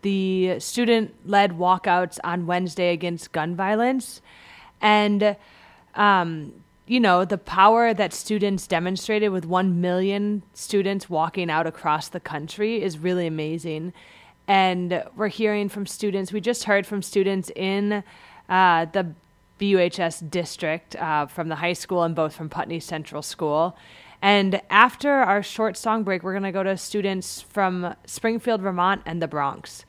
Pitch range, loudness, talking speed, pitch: 170-205 Hz, -23 LUFS, 145 wpm, 185 Hz